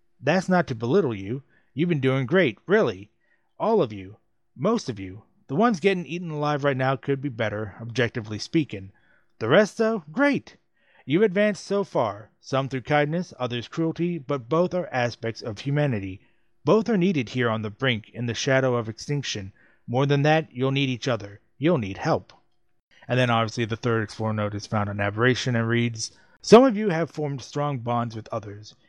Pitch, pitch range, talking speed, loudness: 130 Hz, 115-160 Hz, 190 wpm, -24 LUFS